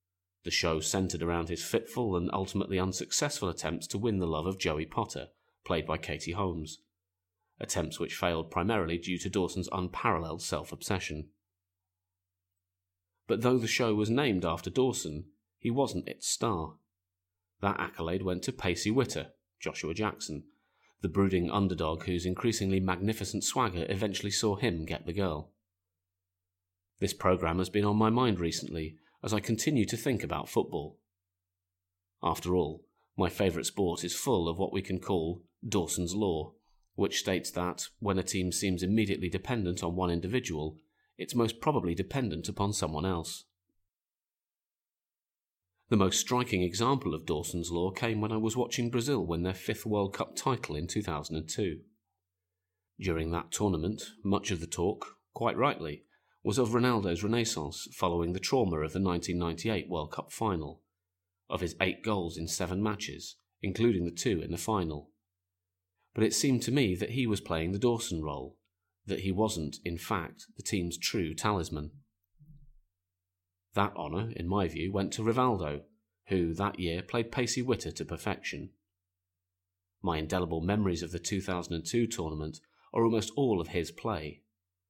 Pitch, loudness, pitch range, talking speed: 90 Hz, -32 LUFS, 85-105 Hz, 155 wpm